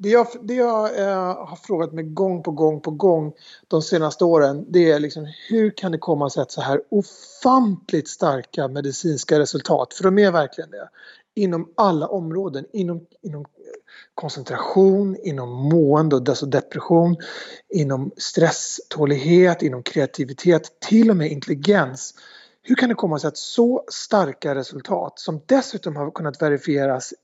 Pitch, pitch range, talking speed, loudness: 165 Hz, 150-195 Hz, 150 wpm, -20 LUFS